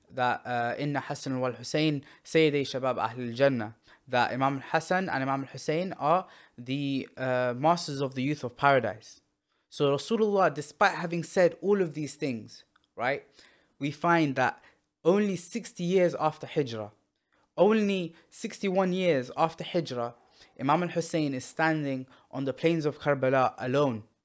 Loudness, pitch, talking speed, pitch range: -28 LUFS, 145 Hz, 145 wpm, 130-170 Hz